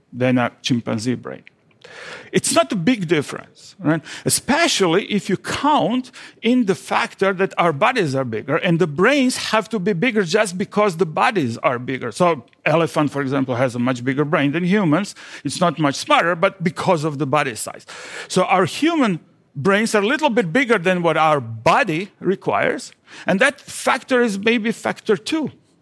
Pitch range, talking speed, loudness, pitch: 150-220 Hz, 180 wpm, -19 LUFS, 185 Hz